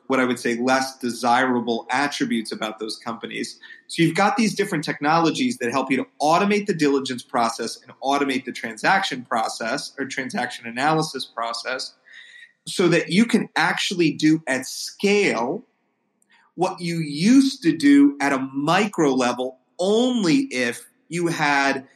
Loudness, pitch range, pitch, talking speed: -21 LUFS, 125-200 Hz, 145 Hz, 150 wpm